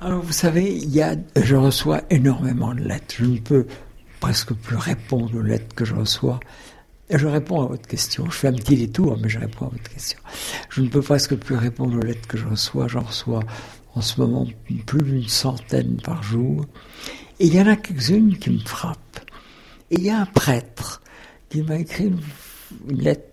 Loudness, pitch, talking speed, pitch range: -21 LUFS, 130 Hz, 205 wpm, 115-150 Hz